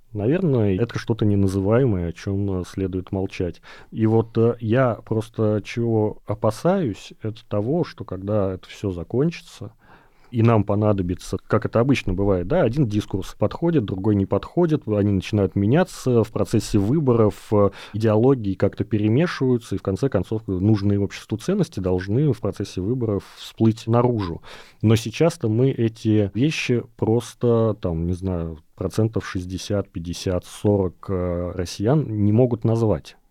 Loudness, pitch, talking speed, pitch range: -22 LUFS, 105 Hz, 135 wpm, 95-120 Hz